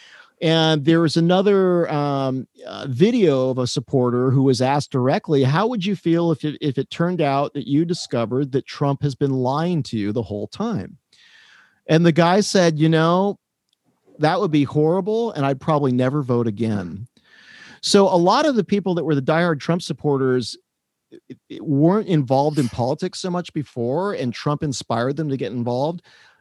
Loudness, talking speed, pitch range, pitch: -20 LUFS, 185 wpm, 130-170 Hz, 150 Hz